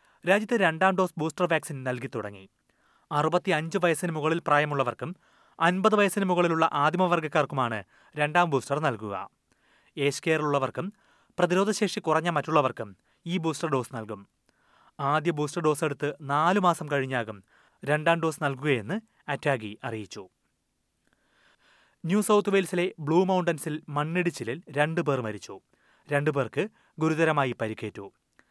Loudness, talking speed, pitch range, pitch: -27 LUFS, 105 wpm, 135-175 Hz, 155 Hz